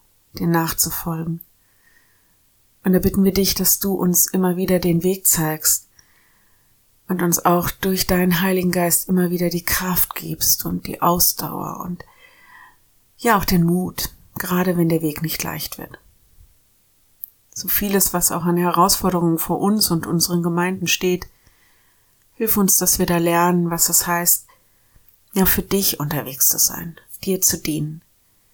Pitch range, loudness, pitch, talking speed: 160-185 Hz, -18 LUFS, 175 Hz, 150 wpm